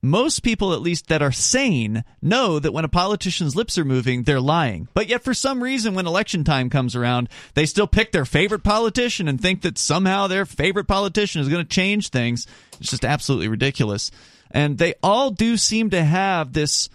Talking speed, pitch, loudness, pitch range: 200 wpm, 165 Hz, -20 LUFS, 135-200 Hz